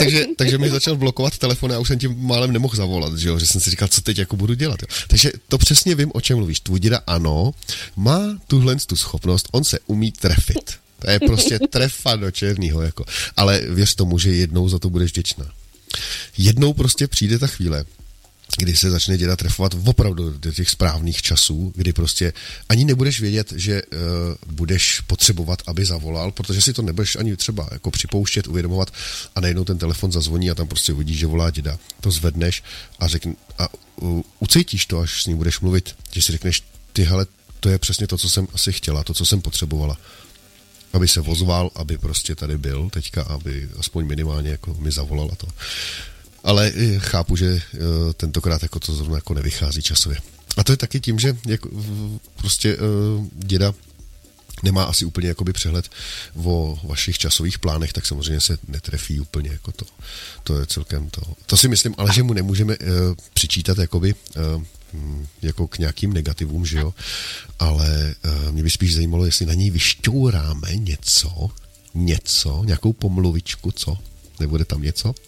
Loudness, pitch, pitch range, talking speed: -19 LUFS, 90 Hz, 80-100 Hz, 175 wpm